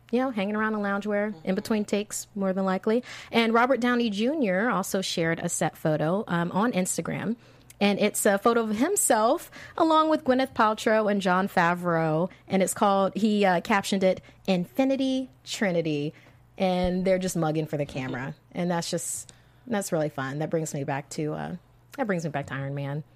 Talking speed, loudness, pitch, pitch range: 185 wpm, -26 LUFS, 190 Hz, 160-220 Hz